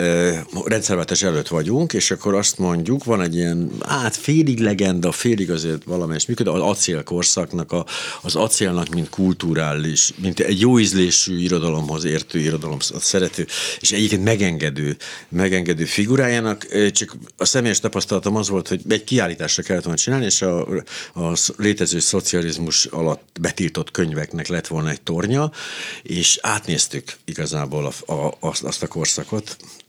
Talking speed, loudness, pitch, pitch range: 145 wpm, -19 LUFS, 90 Hz, 85-105 Hz